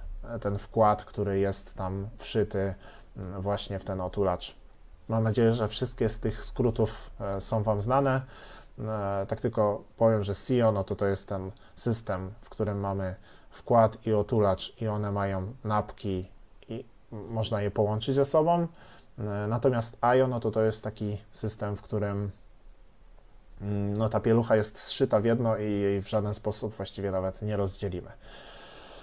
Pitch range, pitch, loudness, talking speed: 100-115 Hz, 105 Hz, -29 LUFS, 150 wpm